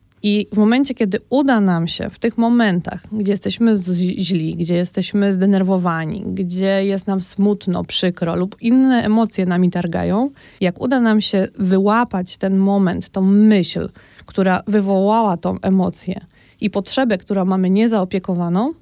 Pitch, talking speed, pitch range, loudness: 195 Hz, 145 wpm, 185-215 Hz, -17 LUFS